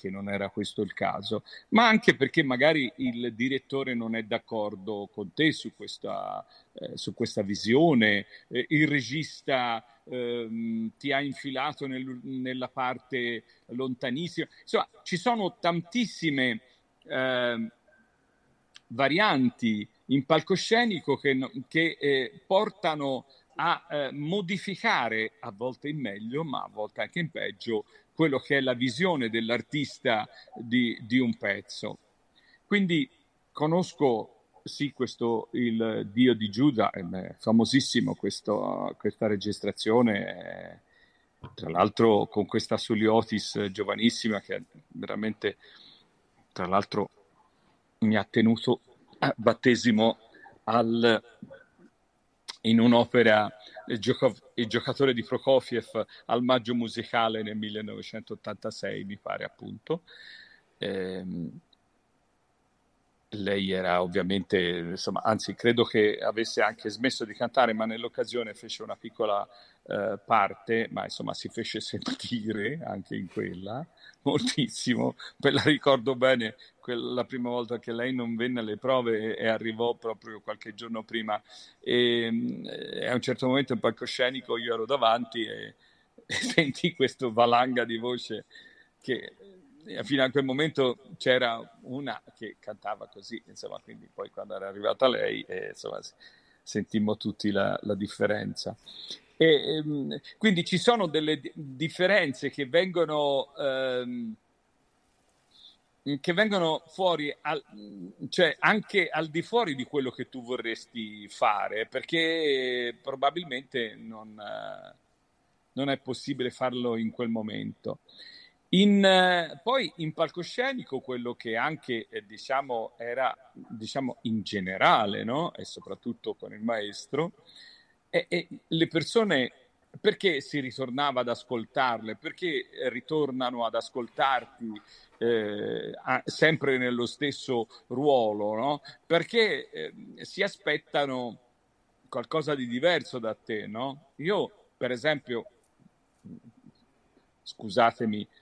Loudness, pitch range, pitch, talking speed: -28 LUFS, 115-150 Hz, 125 Hz, 120 wpm